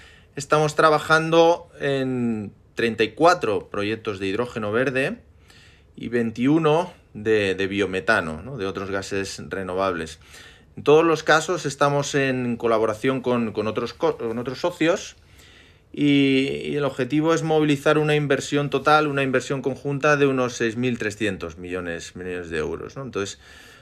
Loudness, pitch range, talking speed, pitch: -22 LUFS, 105-145 Hz, 135 wpm, 130 Hz